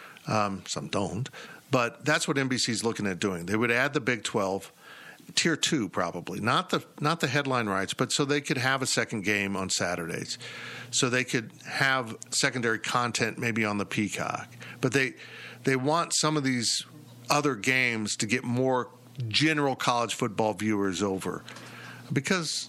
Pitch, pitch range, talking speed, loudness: 125 Hz, 110-140 Hz, 170 wpm, -27 LUFS